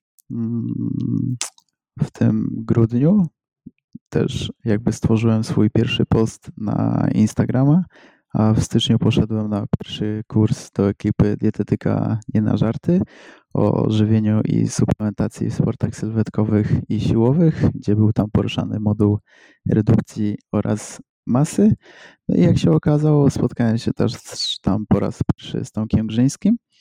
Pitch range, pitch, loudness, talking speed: 105-130 Hz, 110 Hz, -19 LUFS, 125 wpm